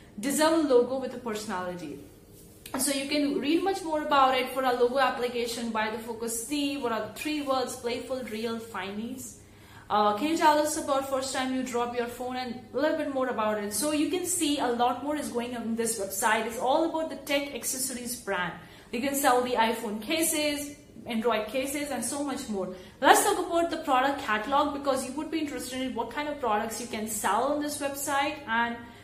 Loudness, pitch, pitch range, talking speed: -28 LUFS, 255 Hz, 230-290 Hz, 215 wpm